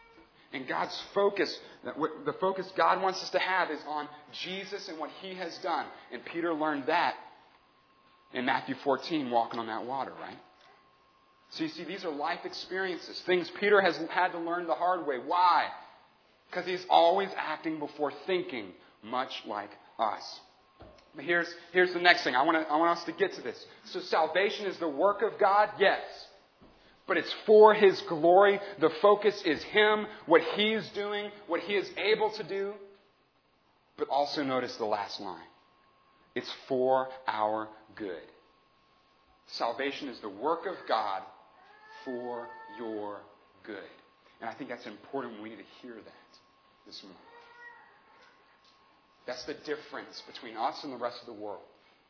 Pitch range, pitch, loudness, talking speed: 150-205 Hz, 180 Hz, -30 LUFS, 160 wpm